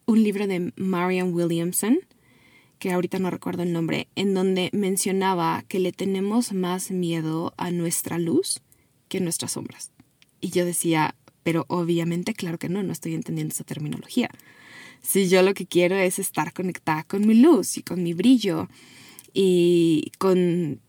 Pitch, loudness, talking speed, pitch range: 180 Hz, -23 LUFS, 160 wpm, 165-190 Hz